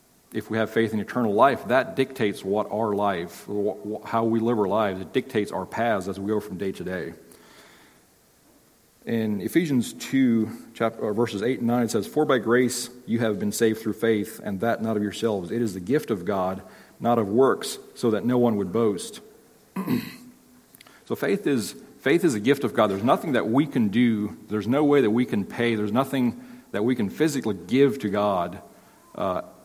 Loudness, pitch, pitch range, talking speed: -25 LUFS, 115 Hz, 105-135 Hz, 200 wpm